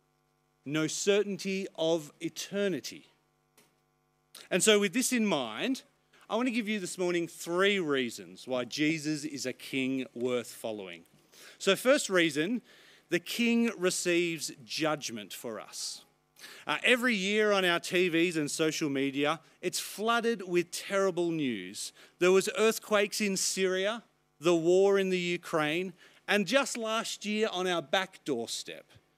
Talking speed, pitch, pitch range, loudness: 140 wpm, 180 Hz, 160-205 Hz, -30 LUFS